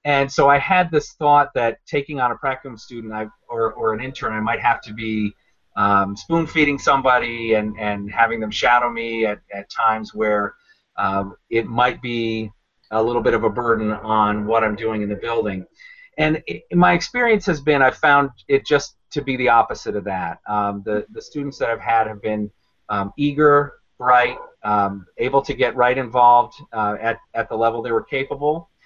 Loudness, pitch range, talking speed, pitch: -19 LUFS, 110-140 Hz, 200 wpm, 115 Hz